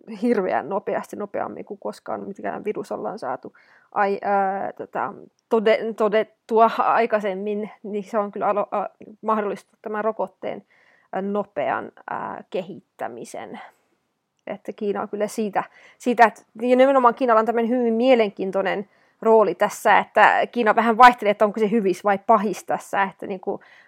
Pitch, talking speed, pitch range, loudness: 215 Hz, 135 wpm, 205-230 Hz, -21 LUFS